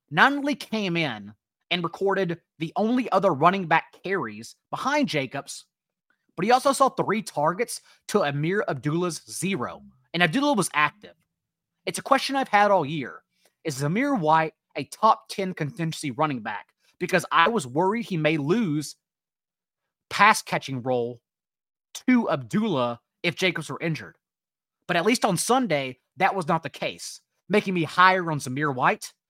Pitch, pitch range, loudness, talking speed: 175 Hz, 150-200 Hz, -24 LUFS, 155 wpm